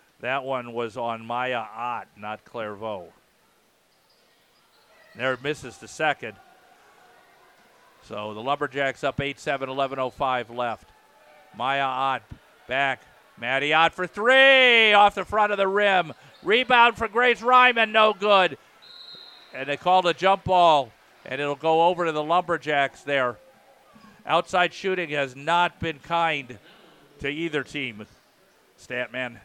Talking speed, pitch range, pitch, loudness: 130 wpm, 130-185 Hz, 145 Hz, -22 LUFS